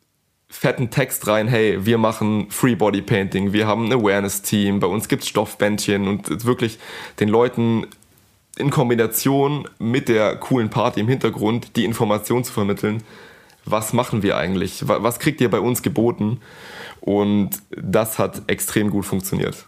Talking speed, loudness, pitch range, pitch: 155 wpm, -20 LUFS, 105-120 Hz, 110 Hz